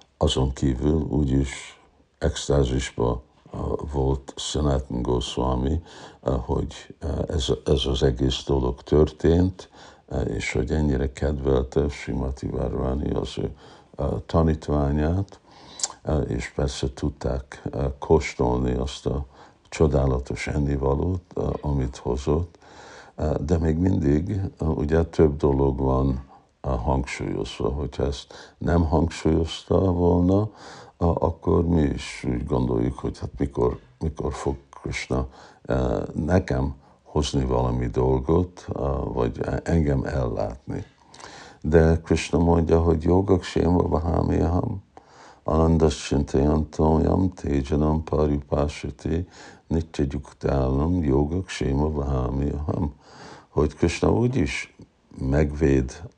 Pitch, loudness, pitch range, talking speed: 75 Hz, -24 LUFS, 65-85 Hz, 100 wpm